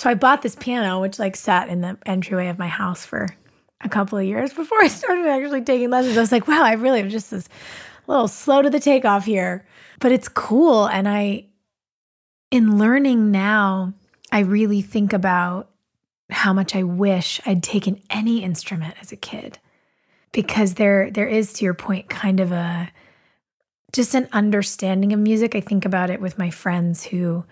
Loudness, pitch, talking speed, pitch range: -19 LUFS, 205 Hz, 190 wpm, 190-235 Hz